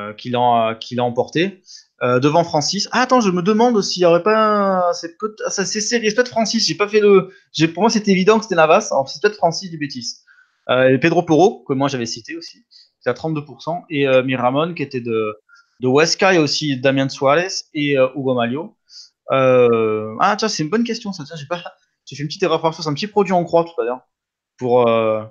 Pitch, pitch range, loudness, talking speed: 165 Hz, 130-205 Hz, -17 LUFS, 230 wpm